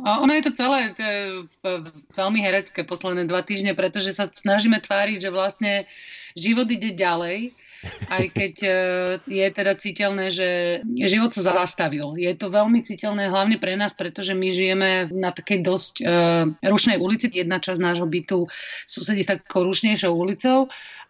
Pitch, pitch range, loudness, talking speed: 195 Hz, 180-210 Hz, -22 LUFS, 155 wpm